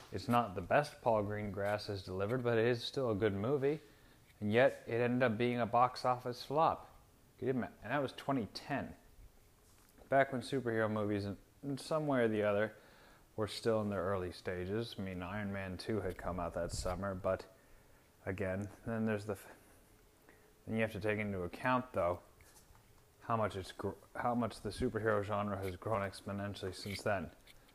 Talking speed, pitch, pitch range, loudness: 180 wpm, 105 Hz, 100-120 Hz, -37 LUFS